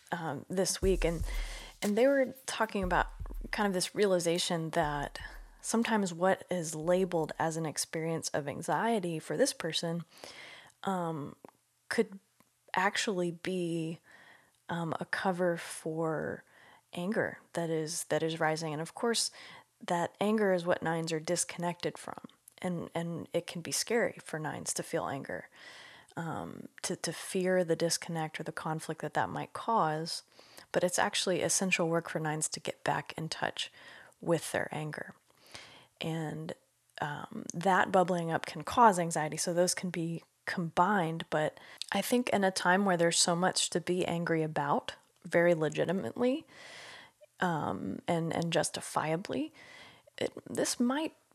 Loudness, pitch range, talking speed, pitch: -32 LUFS, 160-190 Hz, 145 wpm, 175 Hz